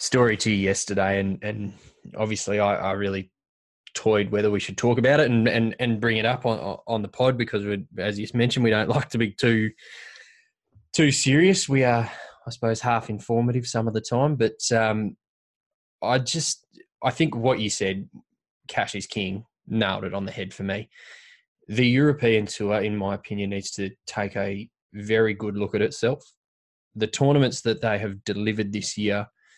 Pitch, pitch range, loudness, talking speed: 110 Hz, 100-120 Hz, -24 LUFS, 185 wpm